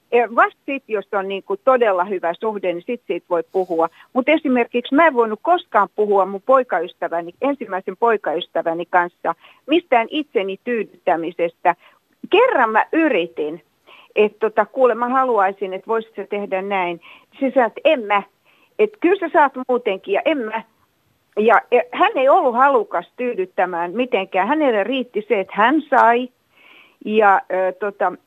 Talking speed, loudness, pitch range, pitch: 150 wpm, -19 LUFS, 185-260 Hz, 215 Hz